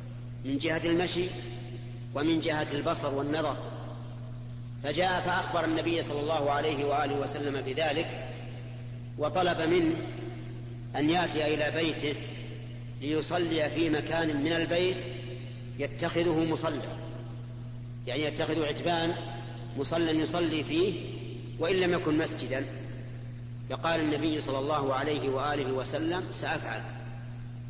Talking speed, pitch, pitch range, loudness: 100 wpm, 140 Hz, 120-160 Hz, -31 LUFS